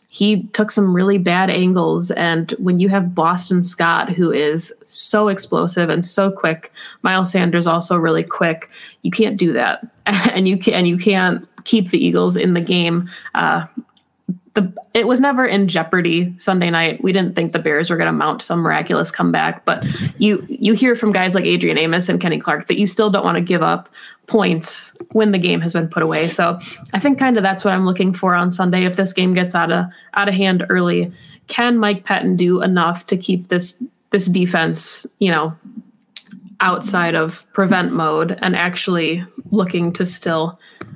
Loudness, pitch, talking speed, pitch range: -17 LUFS, 185 Hz, 195 wpm, 170-205 Hz